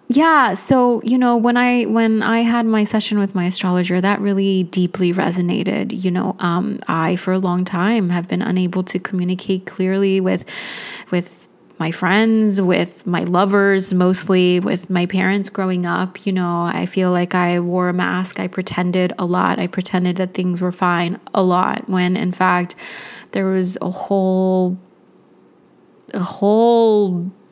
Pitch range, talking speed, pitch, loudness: 180-200 Hz, 165 wpm, 185 Hz, -17 LUFS